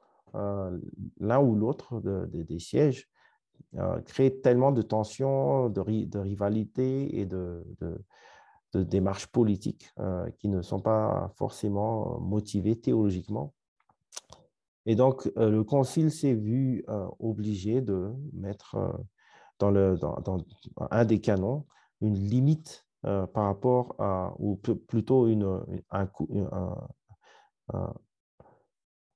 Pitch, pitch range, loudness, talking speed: 105 Hz, 95-125 Hz, -29 LUFS, 135 wpm